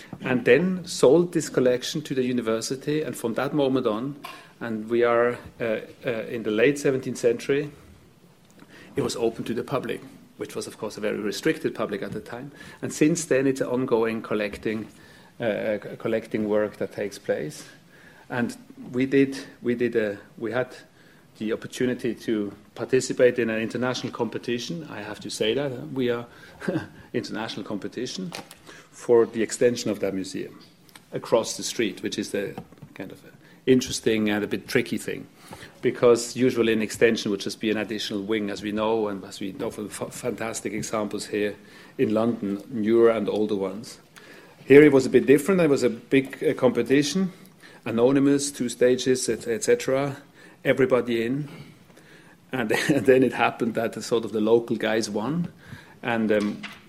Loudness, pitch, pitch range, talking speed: -25 LUFS, 120 Hz, 110-135 Hz, 170 wpm